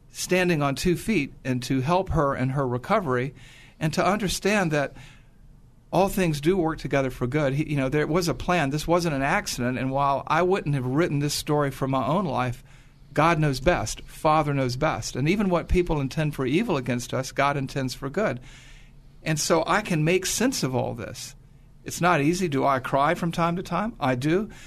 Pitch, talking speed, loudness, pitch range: 145 Hz, 205 wpm, -25 LUFS, 135-170 Hz